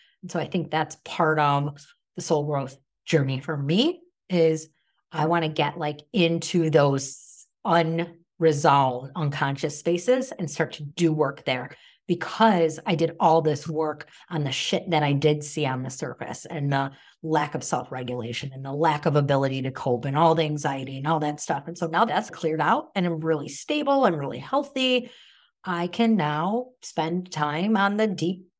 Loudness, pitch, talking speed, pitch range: -25 LUFS, 160 Hz, 180 wpm, 145-175 Hz